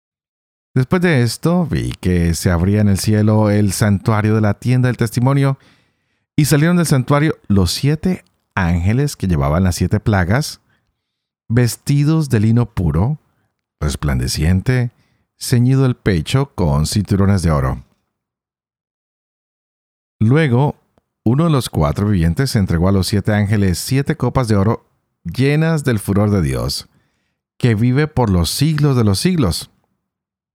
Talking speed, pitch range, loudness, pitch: 135 wpm, 95-135 Hz, -16 LUFS, 115 Hz